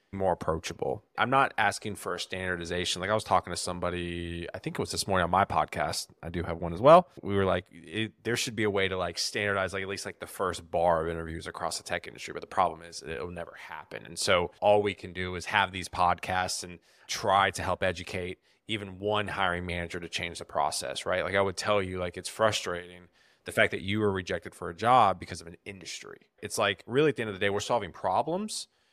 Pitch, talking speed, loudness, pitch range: 90 Hz, 245 wpm, -29 LUFS, 90-100 Hz